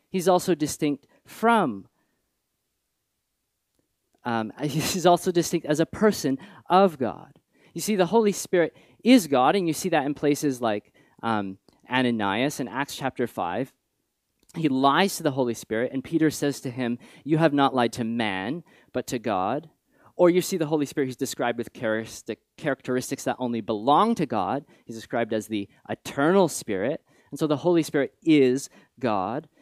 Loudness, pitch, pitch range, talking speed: -25 LUFS, 145 Hz, 120-170 Hz, 165 wpm